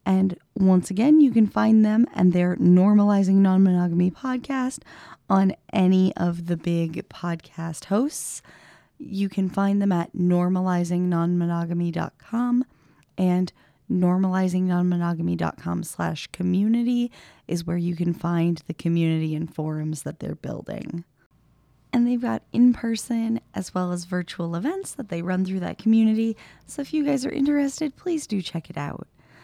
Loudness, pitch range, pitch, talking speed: -23 LUFS, 170-225 Hz, 185 Hz, 135 wpm